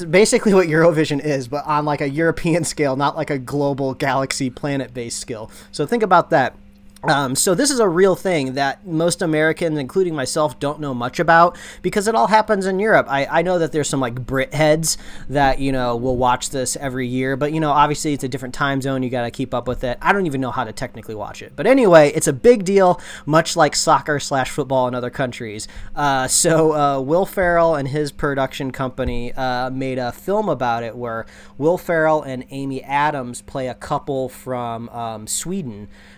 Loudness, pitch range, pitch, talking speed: -19 LUFS, 130-160 Hz, 140 Hz, 210 wpm